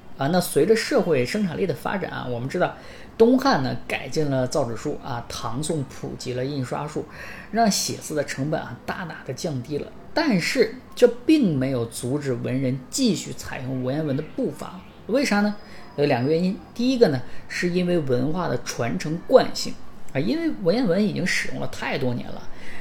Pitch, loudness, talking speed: 160 Hz, -24 LUFS, 275 characters per minute